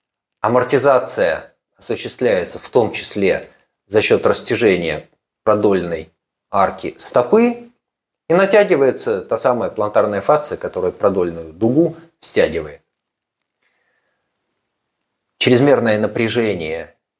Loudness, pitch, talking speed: -16 LUFS, 235 Hz, 80 wpm